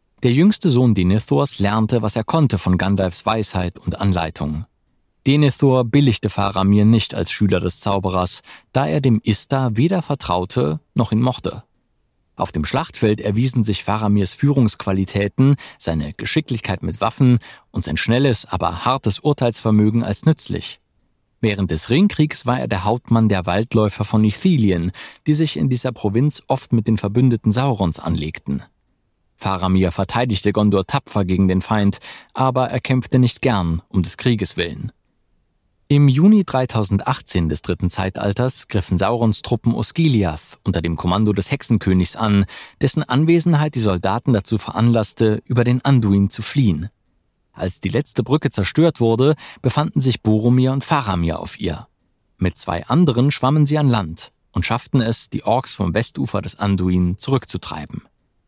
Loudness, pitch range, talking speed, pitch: -18 LUFS, 95-130 Hz, 150 wpm, 110 Hz